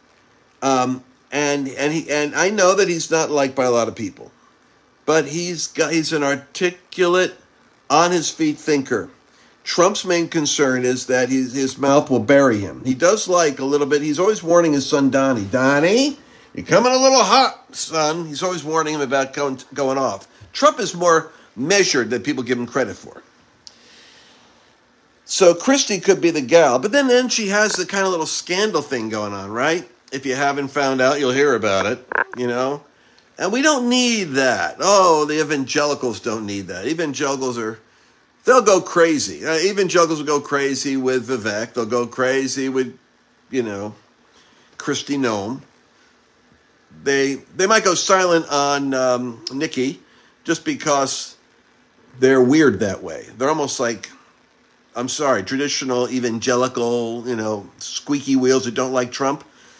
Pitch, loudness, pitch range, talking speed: 140 Hz, -18 LUFS, 130-170 Hz, 160 wpm